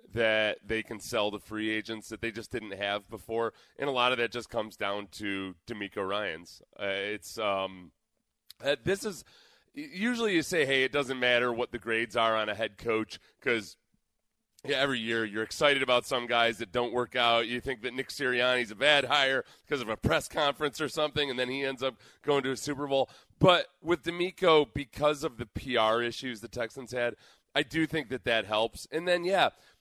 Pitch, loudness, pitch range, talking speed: 125 Hz, -30 LUFS, 110-145 Hz, 205 wpm